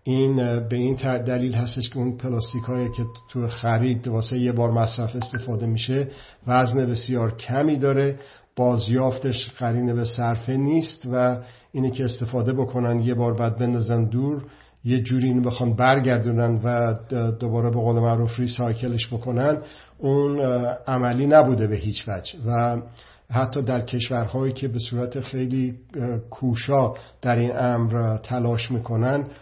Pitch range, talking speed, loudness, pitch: 120-130 Hz, 145 wpm, -23 LUFS, 125 Hz